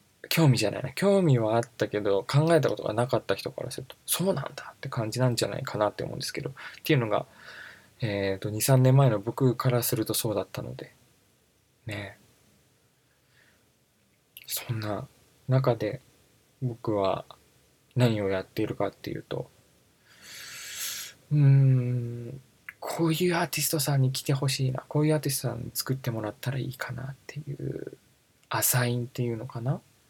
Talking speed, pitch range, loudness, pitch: 330 characters per minute, 115-135 Hz, -27 LUFS, 125 Hz